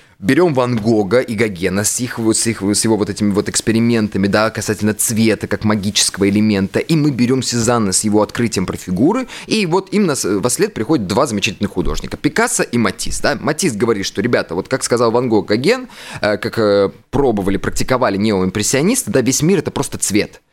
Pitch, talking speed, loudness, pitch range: 110 Hz, 185 wpm, -16 LUFS, 105-130 Hz